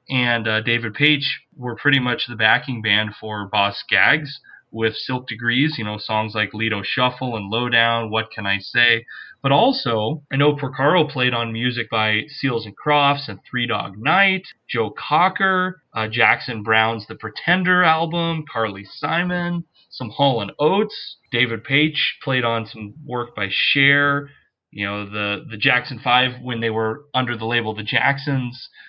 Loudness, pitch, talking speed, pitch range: -19 LUFS, 120 Hz, 165 wpm, 110-145 Hz